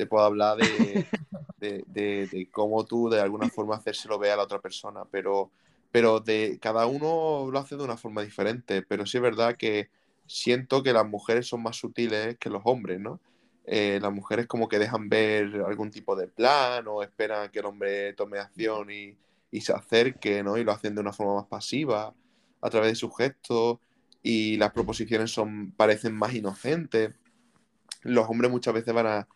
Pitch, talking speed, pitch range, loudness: 110 Hz, 190 wpm, 105-120 Hz, -27 LUFS